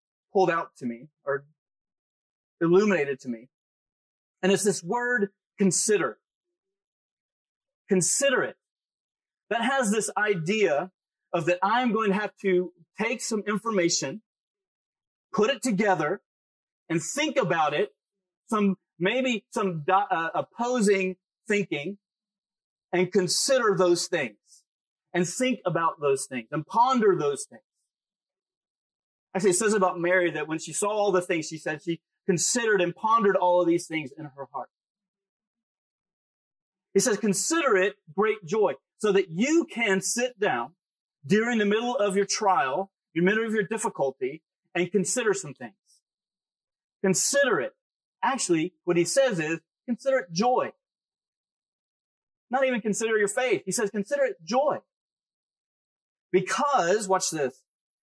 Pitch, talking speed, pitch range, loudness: 195 Hz, 135 wpm, 175-220 Hz, -26 LUFS